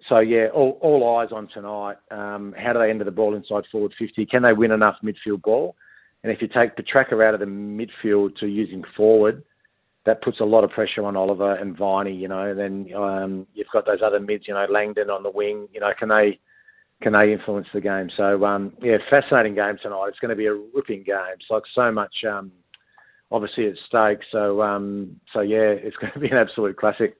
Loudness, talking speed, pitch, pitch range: -21 LUFS, 225 wpm, 105 Hz, 100-110 Hz